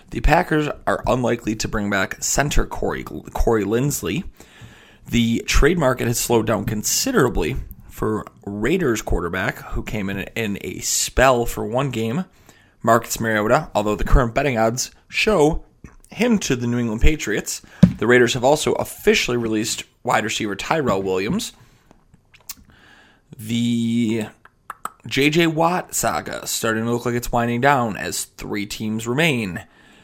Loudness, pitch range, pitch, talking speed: -20 LUFS, 110-125 Hz, 115 Hz, 140 wpm